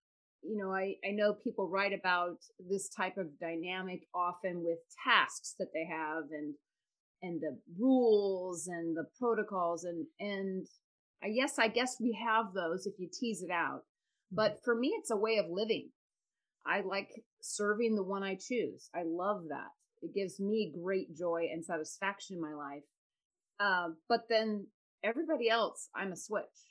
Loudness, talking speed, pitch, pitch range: -35 LUFS, 170 wpm, 195 Hz, 175-220 Hz